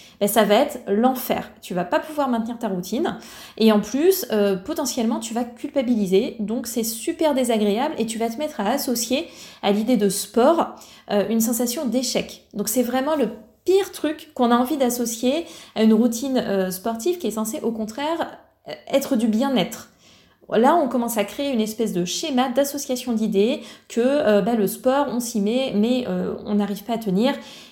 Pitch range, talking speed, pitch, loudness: 210-265 Hz, 195 wpm, 235 Hz, -22 LUFS